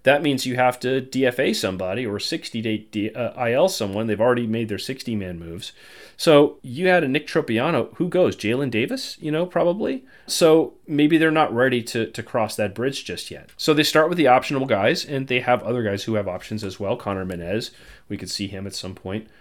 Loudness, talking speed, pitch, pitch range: -22 LUFS, 225 wpm, 125 Hz, 105-150 Hz